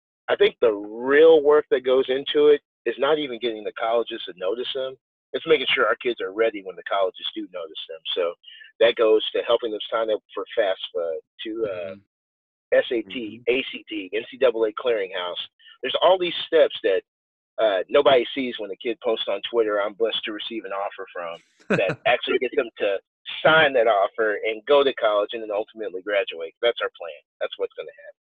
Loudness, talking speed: -23 LUFS, 195 wpm